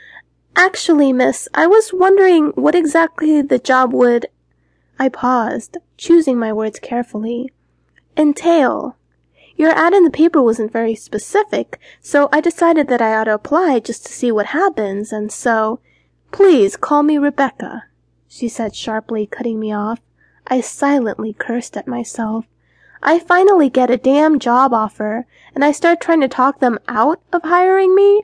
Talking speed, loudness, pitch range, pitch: 155 wpm, -15 LUFS, 225-335 Hz, 265 Hz